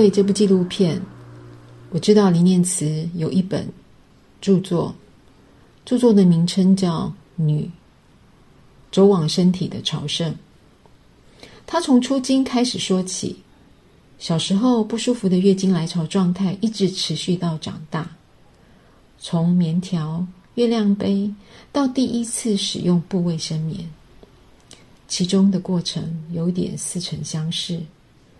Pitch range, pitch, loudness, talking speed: 165-200 Hz, 180 Hz, -20 LUFS, 180 characters per minute